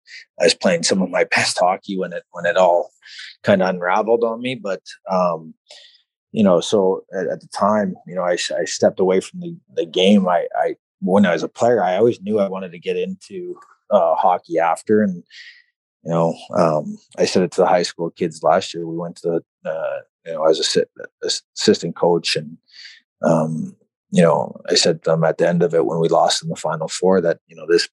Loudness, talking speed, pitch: -19 LUFS, 230 wpm, 120 Hz